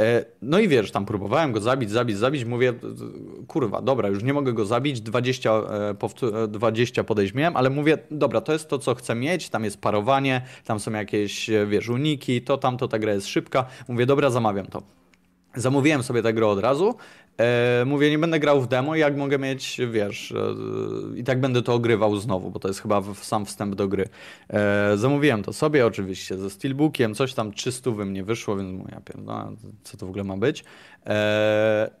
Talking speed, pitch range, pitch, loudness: 200 wpm, 105-135 Hz, 115 Hz, -23 LUFS